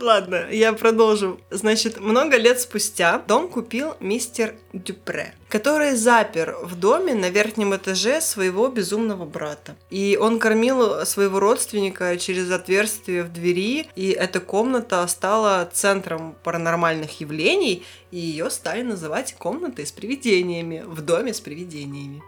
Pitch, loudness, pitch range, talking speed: 200 Hz, -21 LUFS, 175-225 Hz, 130 wpm